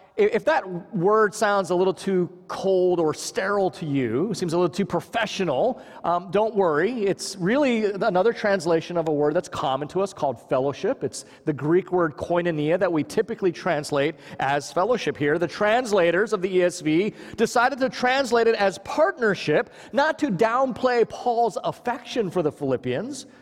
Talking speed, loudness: 165 wpm, -23 LUFS